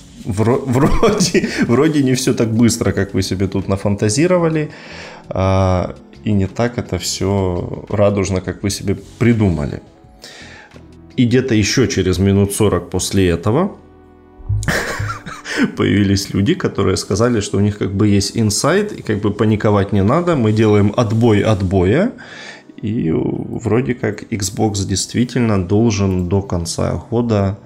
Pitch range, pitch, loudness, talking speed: 95-115 Hz, 100 Hz, -16 LUFS, 130 wpm